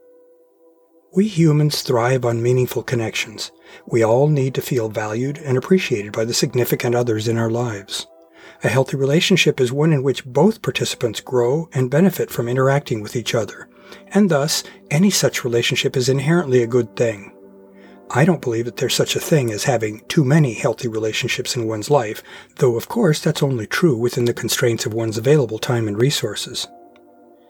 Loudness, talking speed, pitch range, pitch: -19 LUFS, 175 wpm, 120-150 Hz, 130 Hz